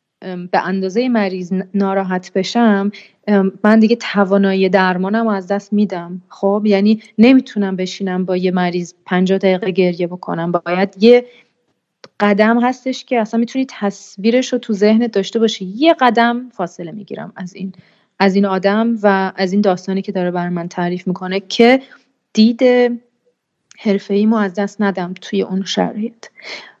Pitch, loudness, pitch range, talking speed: 200 Hz, -15 LUFS, 190-225 Hz, 150 wpm